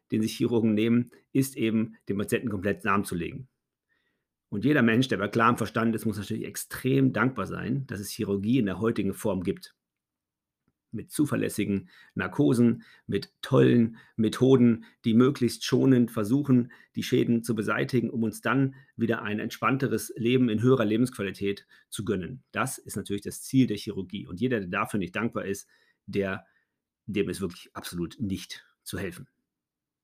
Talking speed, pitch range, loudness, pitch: 160 wpm, 105-125 Hz, -27 LUFS, 115 Hz